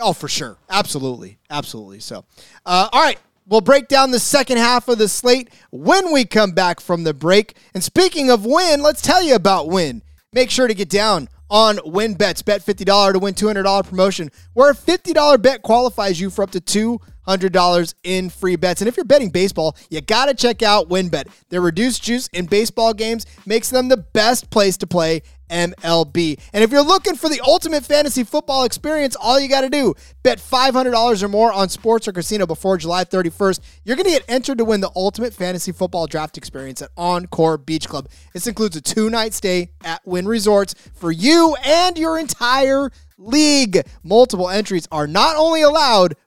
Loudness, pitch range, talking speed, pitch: -16 LUFS, 180-255 Hz, 200 wpm, 210 Hz